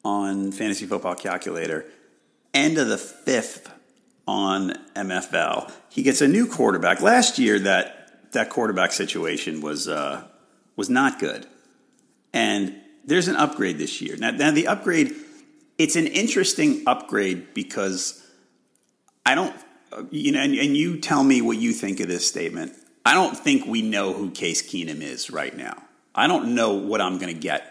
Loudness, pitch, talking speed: -22 LUFS, 240 Hz, 160 wpm